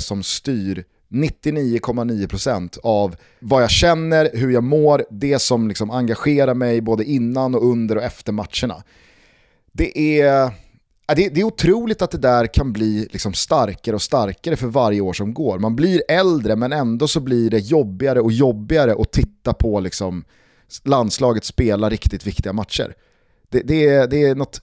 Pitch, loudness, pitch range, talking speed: 120 Hz, -18 LUFS, 105-140 Hz, 160 wpm